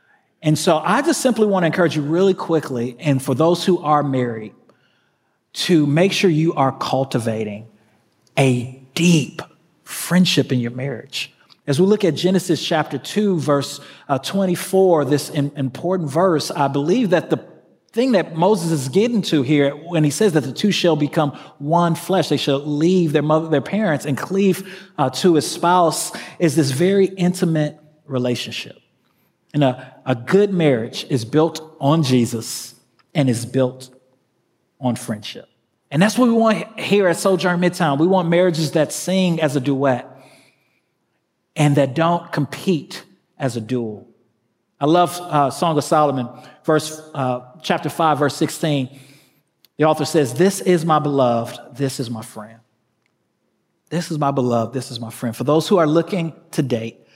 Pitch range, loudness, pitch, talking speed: 130-175 Hz, -19 LUFS, 150 Hz, 165 wpm